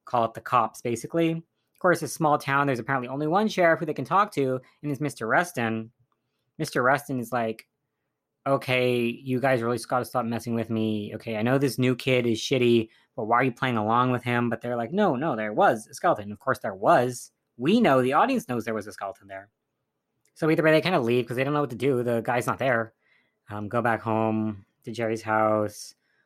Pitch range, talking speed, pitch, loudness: 115-140 Hz, 240 wpm, 125 Hz, -25 LUFS